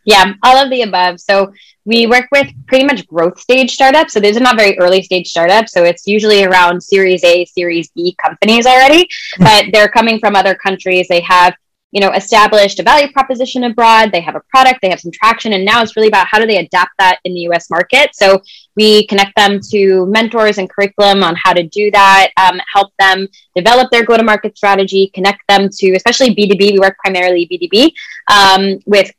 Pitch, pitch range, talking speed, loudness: 200 Hz, 185-225 Hz, 205 wpm, -9 LUFS